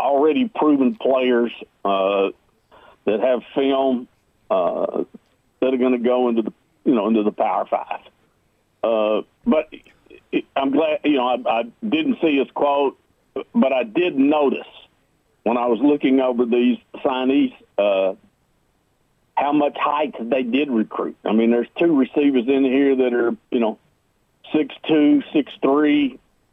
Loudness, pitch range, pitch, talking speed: -20 LUFS, 120-145 Hz, 130 Hz, 150 wpm